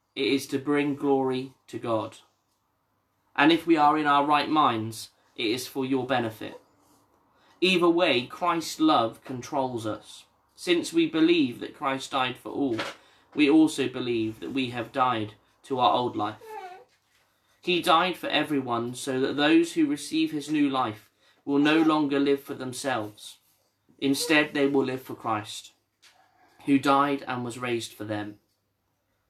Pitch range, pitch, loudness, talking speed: 110-150 Hz, 135 Hz, -25 LUFS, 155 wpm